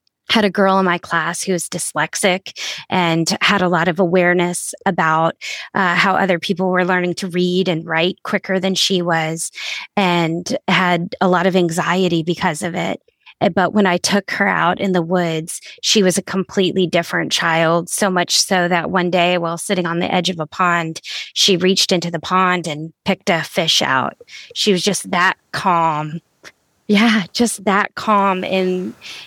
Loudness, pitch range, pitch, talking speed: -17 LUFS, 170-195 Hz, 180 Hz, 180 wpm